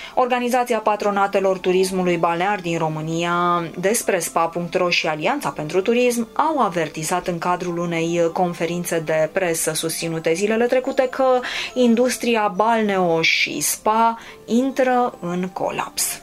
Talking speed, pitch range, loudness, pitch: 115 wpm, 170-230 Hz, -20 LUFS, 185 Hz